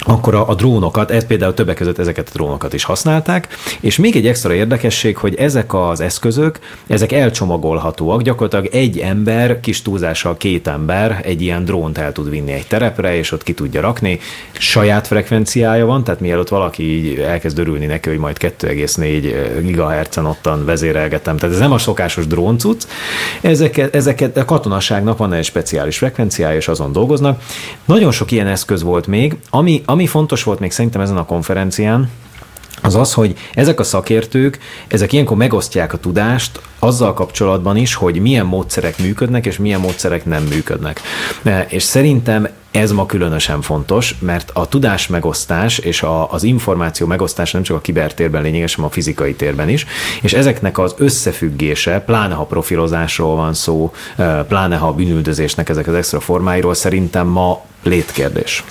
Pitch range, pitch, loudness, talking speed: 85-115 Hz, 95 Hz, -15 LUFS, 160 wpm